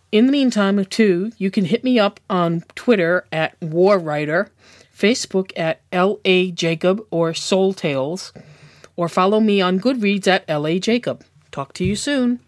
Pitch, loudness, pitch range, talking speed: 190 Hz, -18 LUFS, 170-210 Hz, 160 wpm